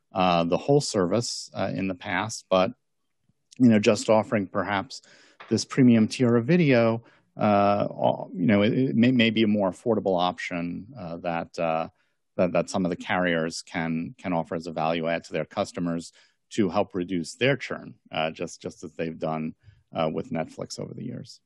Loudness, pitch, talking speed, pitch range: -25 LUFS, 95 Hz, 190 wpm, 85-110 Hz